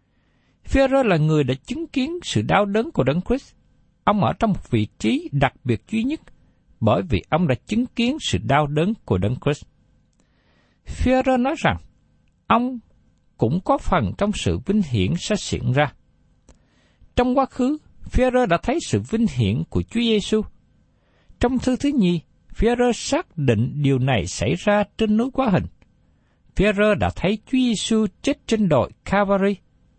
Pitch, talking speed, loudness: 210 Hz, 170 wpm, -21 LUFS